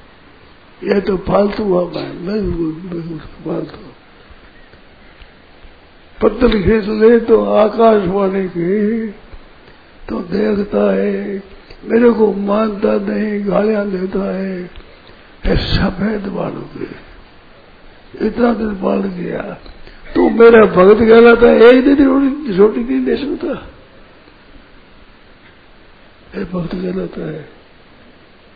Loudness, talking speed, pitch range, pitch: -13 LUFS, 90 wpm, 185-220 Hz, 205 Hz